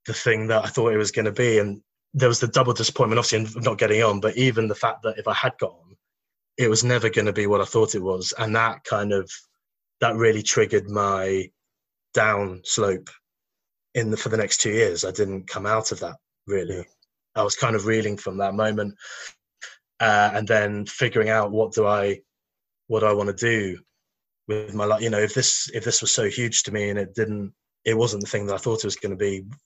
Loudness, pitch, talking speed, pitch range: -22 LUFS, 110 Hz, 235 wpm, 100-115 Hz